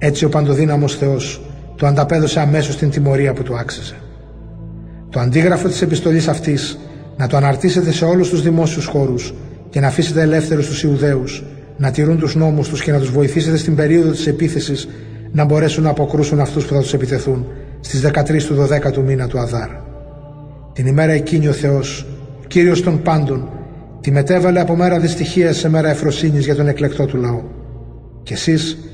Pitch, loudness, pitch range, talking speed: 145 Hz, -15 LUFS, 140-160 Hz, 175 wpm